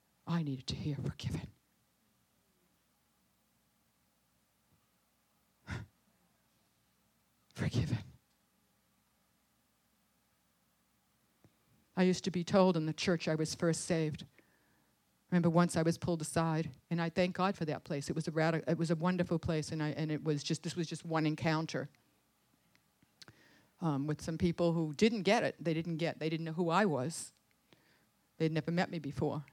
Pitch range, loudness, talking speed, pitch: 155-175 Hz, -35 LUFS, 150 wpm, 165 Hz